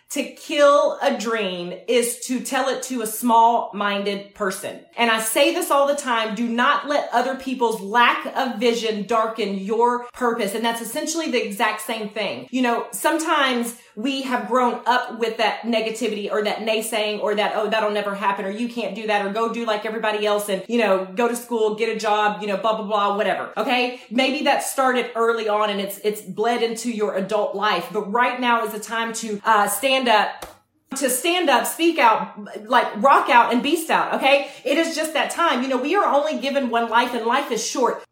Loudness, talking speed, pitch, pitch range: -21 LUFS, 215 wpm, 230 Hz, 215-255 Hz